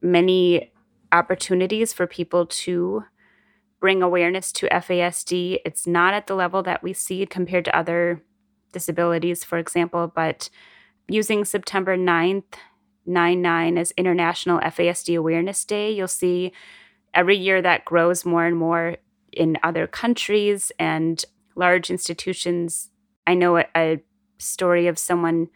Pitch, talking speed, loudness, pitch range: 180 Hz, 130 wpm, -21 LUFS, 170-190 Hz